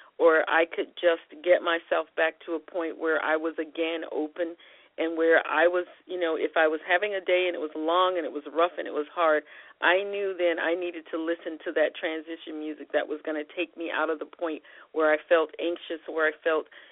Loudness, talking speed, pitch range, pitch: -27 LUFS, 240 wpm, 155-175 Hz, 165 Hz